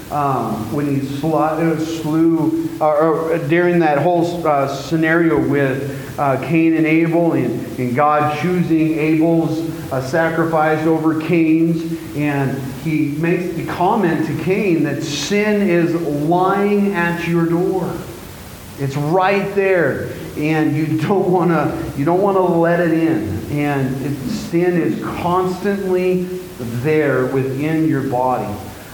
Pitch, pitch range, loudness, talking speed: 160 Hz, 145-170 Hz, -17 LUFS, 130 wpm